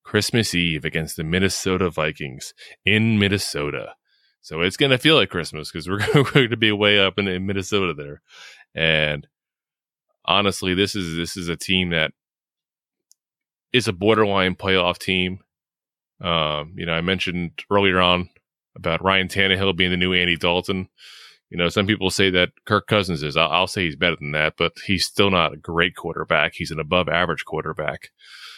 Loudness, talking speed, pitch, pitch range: -20 LUFS, 175 wpm, 90 Hz, 85-100 Hz